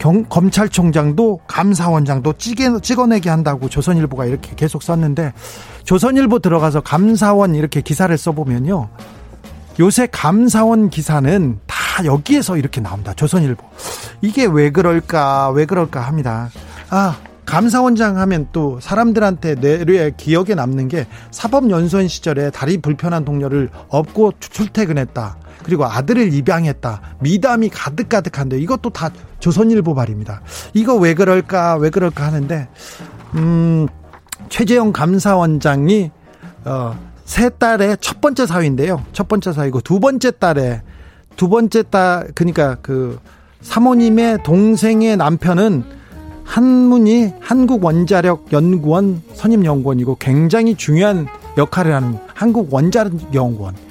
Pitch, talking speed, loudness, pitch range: 165 Hz, 295 characters per minute, -15 LUFS, 140-210 Hz